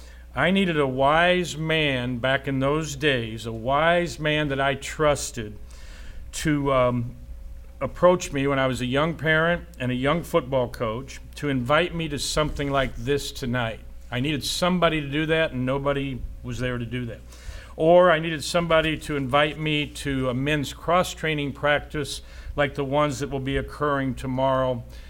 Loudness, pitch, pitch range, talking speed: -24 LUFS, 140 Hz, 125-155 Hz, 170 wpm